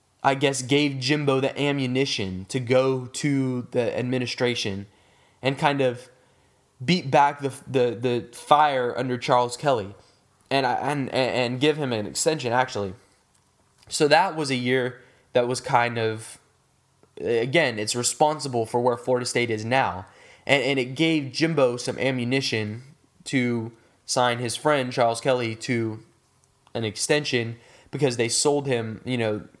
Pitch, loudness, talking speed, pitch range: 125 Hz, -24 LUFS, 145 wpm, 120-135 Hz